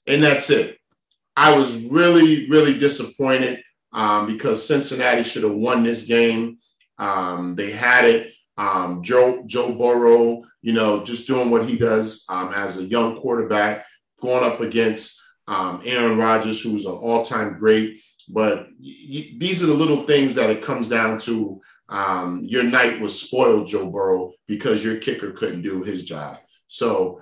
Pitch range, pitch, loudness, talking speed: 110-130 Hz, 115 Hz, -19 LUFS, 160 wpm